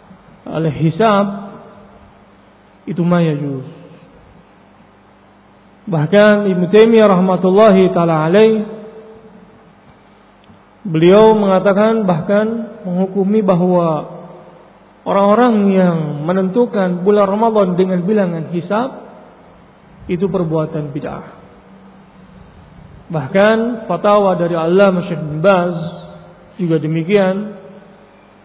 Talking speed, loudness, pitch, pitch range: 75 wpm, -14 LUFS, 195 Hz, 175-210 Hz